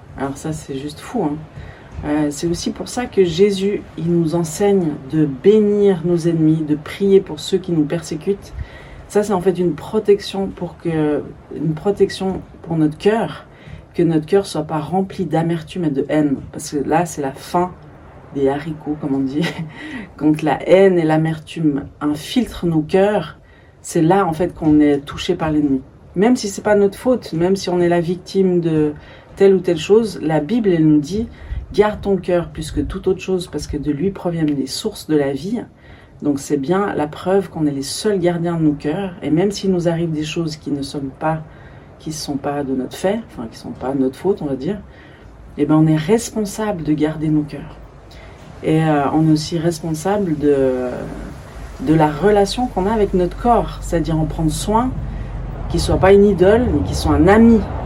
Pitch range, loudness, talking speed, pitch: 150-195 Hz, -18 LUFS, 205 wpm, 165 Hz